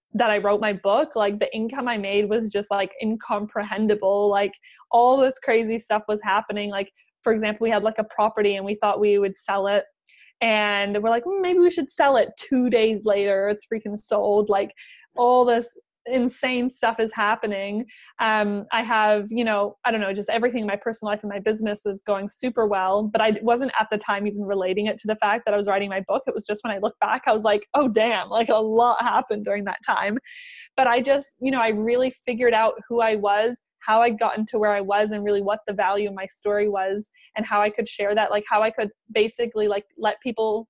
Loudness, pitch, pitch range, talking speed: -22 LUFS, 215 Hz, 205-235 Hz, 230 wpm